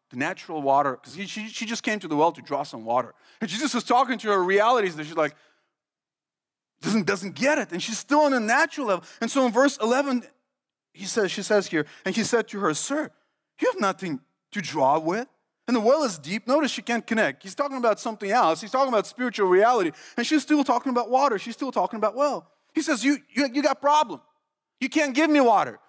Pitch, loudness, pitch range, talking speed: 235 Hz, -24 LUFS, 195-280 Hz, 235 wpm